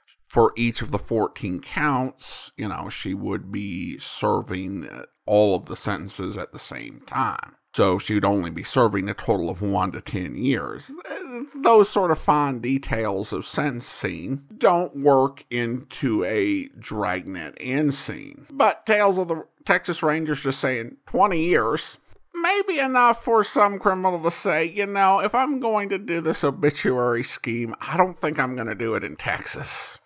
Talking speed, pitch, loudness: 170 wpm, 150 Hz, -23 LUFS